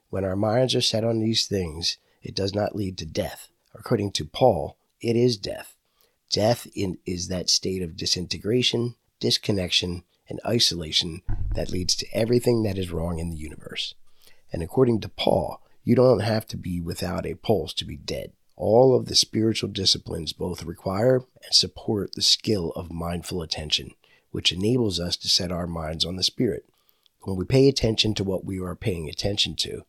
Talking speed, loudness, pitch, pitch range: 180 wpm, -24 LUFS, 95 Hz, 85-110 Hz